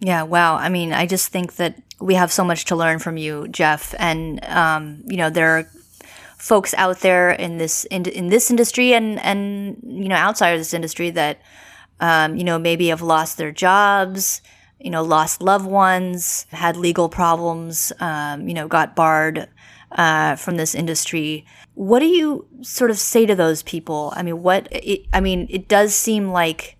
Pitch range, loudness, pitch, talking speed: 160-195 Hz, -18 LUFS, 175 Hz, 190 wpm